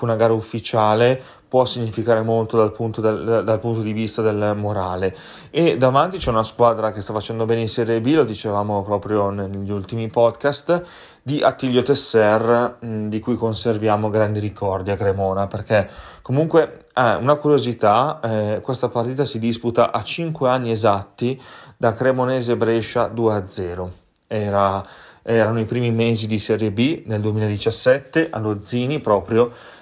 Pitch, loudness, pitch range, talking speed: 115 Hz, -20 LUFS, 105-120 Hz, 150 wpm